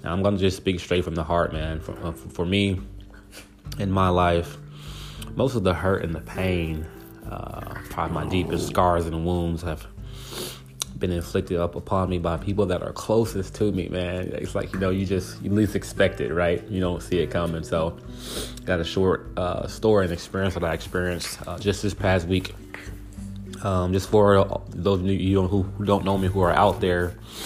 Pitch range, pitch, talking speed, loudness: 85-100 Hz, 95 Hz, 200 wpm, -25 LUFS